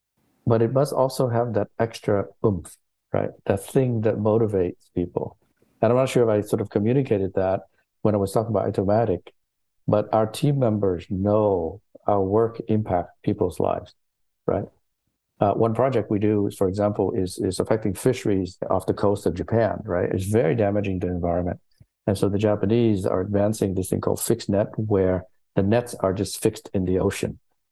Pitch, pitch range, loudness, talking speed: 105 Hz, 95-115 Hz, -23 LUFS, 180 wpm